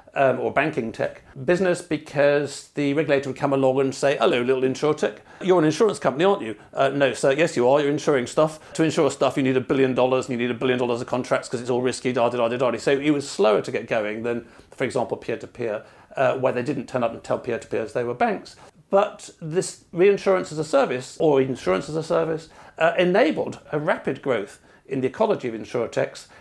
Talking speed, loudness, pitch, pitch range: 235 wpm, -23 LUFS, 140 Hz, 130-160 Hz